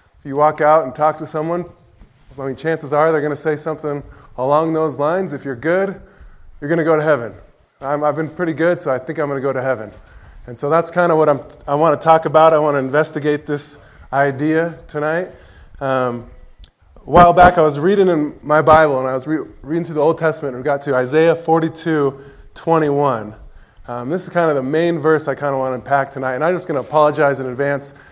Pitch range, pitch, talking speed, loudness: 135-160 Hz, 150 Hz, 235 wpm, -17 LUFS